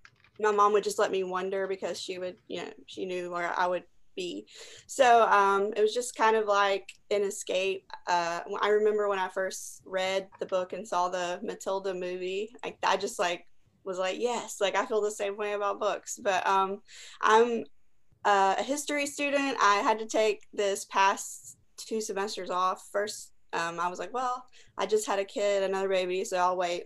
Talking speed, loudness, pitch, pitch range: 195 wpm, -29 LUFS, 200 Hz, 185-215 Hz